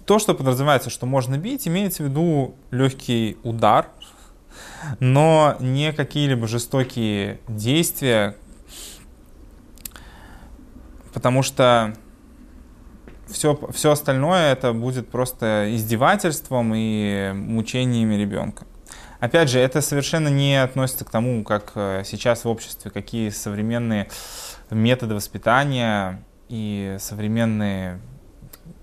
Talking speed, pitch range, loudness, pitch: 95 wpm, 105-135 Hz, -21 LUFS, 120 Hz